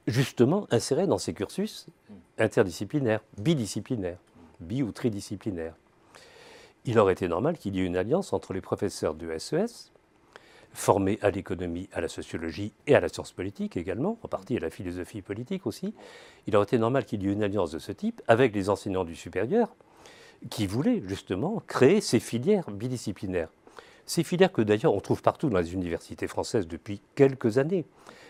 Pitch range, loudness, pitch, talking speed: 95-135 Hz, -28 LUFS, 105 Hz, 170 wpm